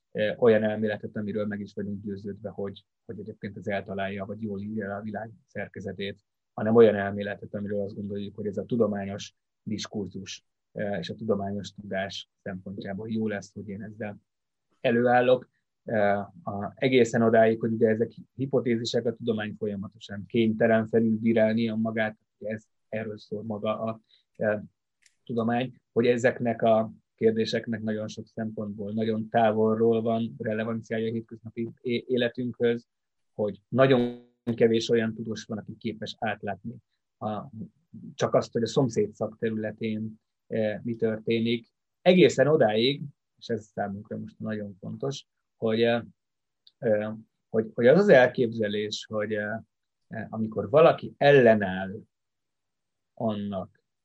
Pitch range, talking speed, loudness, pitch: 105-115 Hz, 130 wpm, -27 LUFS, 110 Hz